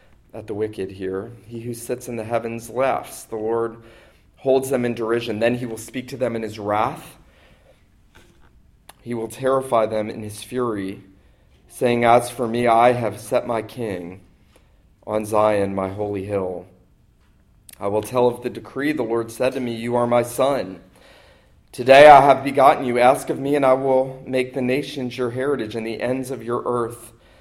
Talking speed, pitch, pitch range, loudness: 185 wpm, 120 Hz, 110-125 Hz, -20 LUFS